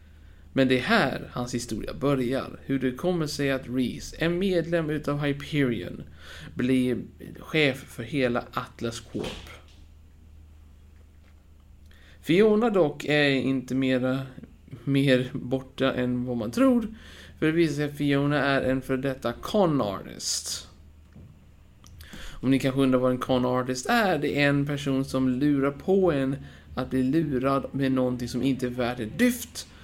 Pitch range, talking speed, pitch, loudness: 120-140 Hz, 145 wpm, 130 Hz, -26 LUFS